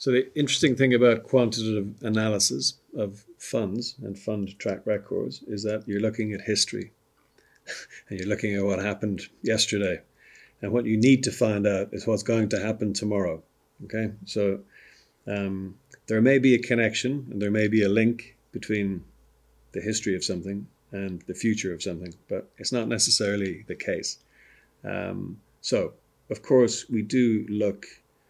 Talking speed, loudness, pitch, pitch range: 160 wpm, -26 LUFS, 105 Hz, 100-115 Hz